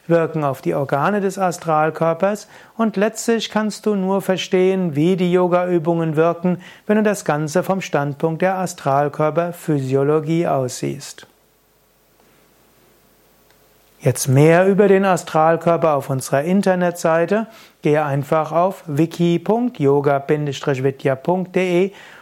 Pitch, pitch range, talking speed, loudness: 170 Hz, 150-185 Hz, 105 wpm, -18 LUFS